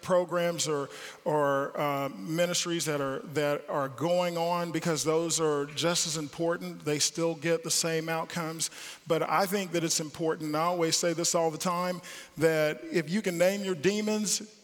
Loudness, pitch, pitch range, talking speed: -29 LUFS, 165 Hz, 155-175 Hz, 180 wpm